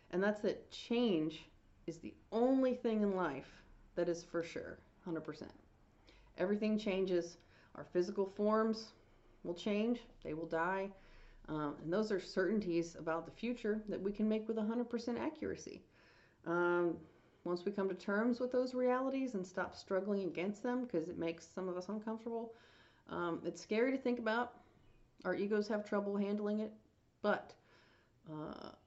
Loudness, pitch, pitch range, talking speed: -39 LUFS, 195 Hz, 170-220 Hz, 155 wpm